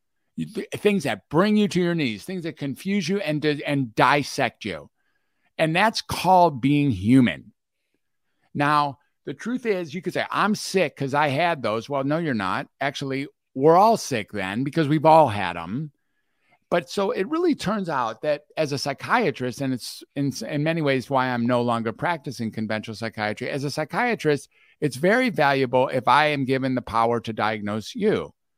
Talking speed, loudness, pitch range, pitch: 180 wpm, -23 LUFS, 130-170 Hz, 145 Hz